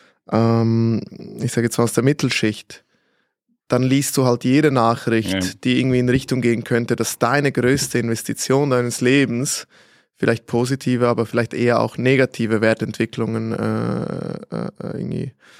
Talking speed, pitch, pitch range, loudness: 140 wpm, 120 Hz, 115-130 Hz, -19 LUFS